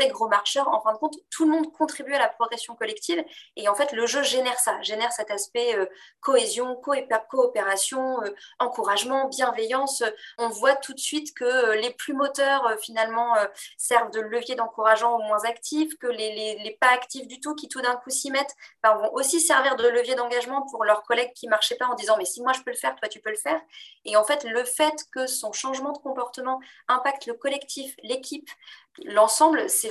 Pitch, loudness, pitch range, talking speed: 250 Hz, -24 LUFS, 225-285 Hz, 215 wpm